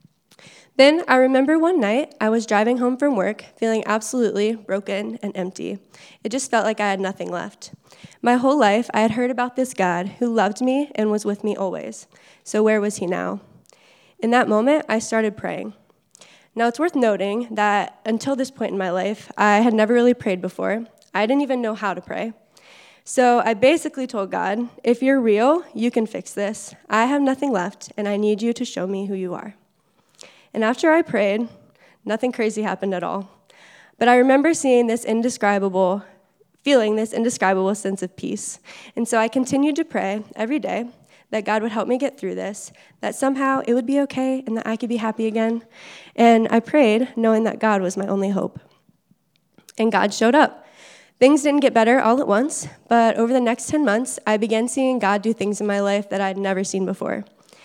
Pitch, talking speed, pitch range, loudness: 225 Hz, 200 wpm, 205-250 Hz, -20 LUFS